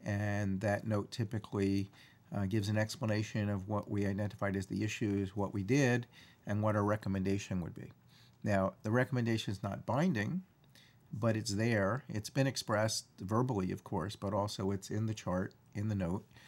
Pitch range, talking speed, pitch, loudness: 100-115 Hz, 175 wpm, 105 Hz, -36 LUFS